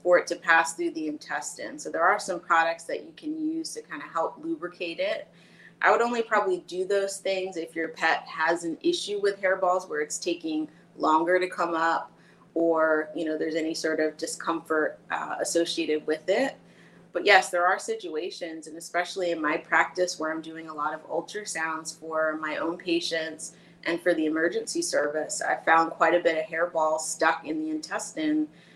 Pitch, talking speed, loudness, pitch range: 170 Hz, 195 wpm, -27 LUFS, 160-195 Hz